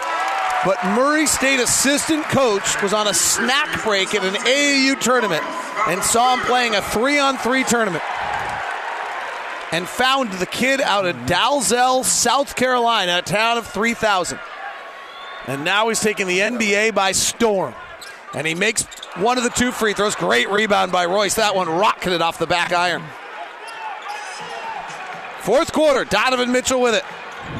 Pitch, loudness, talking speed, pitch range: 230 Hz, -18 LUFS, 150 wpm, 195-255 Hz